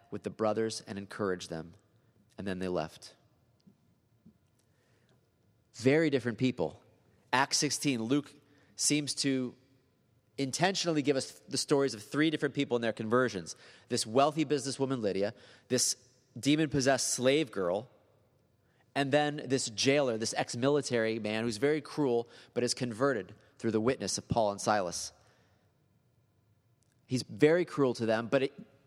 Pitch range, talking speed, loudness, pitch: 110-140 Hz, 140 wpm, -31 LUFS, 125 Hz